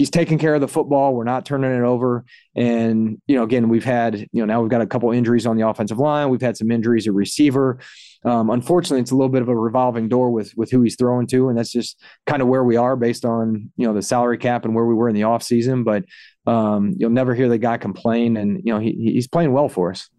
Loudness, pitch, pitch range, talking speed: -19 LUFS, 120 Hz, 115-130 Hz, 270 wpm